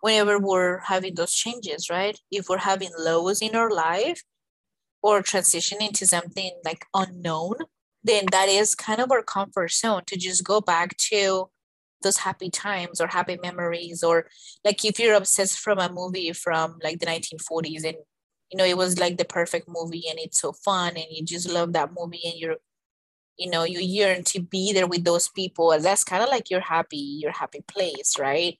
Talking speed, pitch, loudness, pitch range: 190 wpm, 180 Hz, -24 LUFS, 170-195 Hz